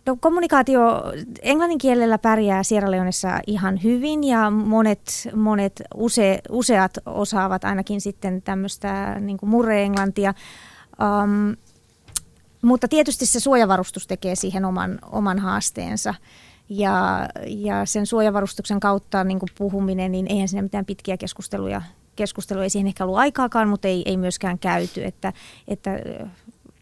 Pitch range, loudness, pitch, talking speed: 190-220 Hz, -21 LUFS, 200 Hz, 130 wpm